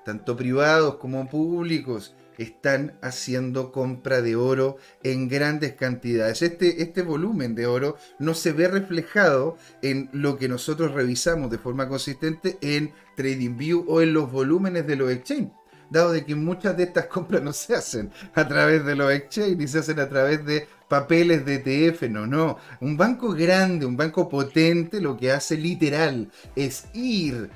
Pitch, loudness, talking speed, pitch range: 145 Hz, -24 LUFS, 165 wpm, 130-165 Hz